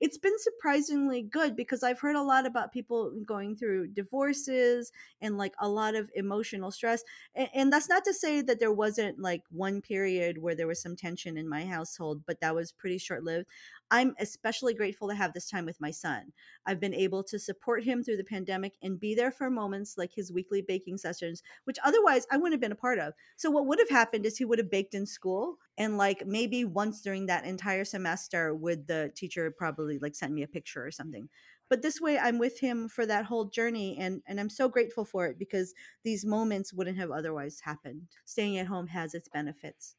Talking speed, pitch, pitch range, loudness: 220 wpm, 205 Hz, 180-240 Hz, -32 LUFS